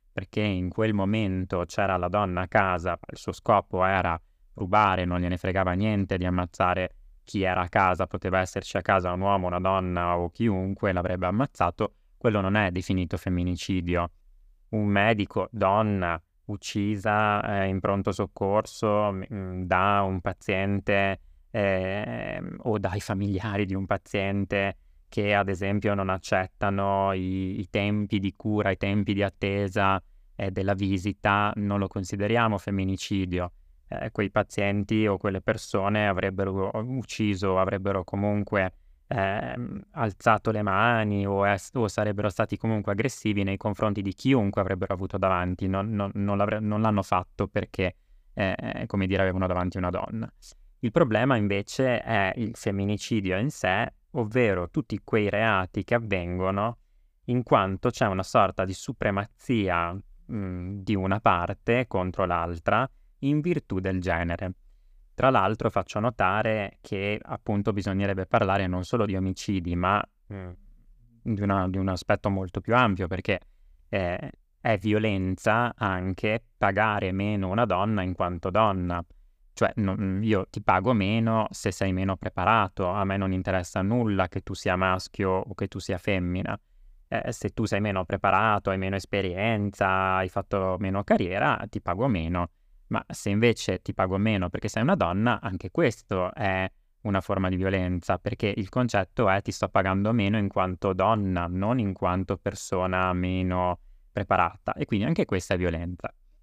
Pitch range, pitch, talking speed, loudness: 95-105 Hz, 100 Hz, 150 wpm, -27 LUFS